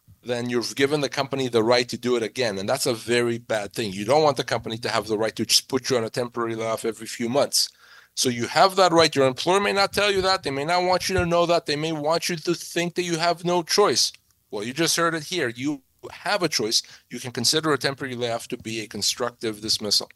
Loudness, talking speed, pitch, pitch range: -23 LUFS, 265 wpm, 130 Hz, 115-170 Hz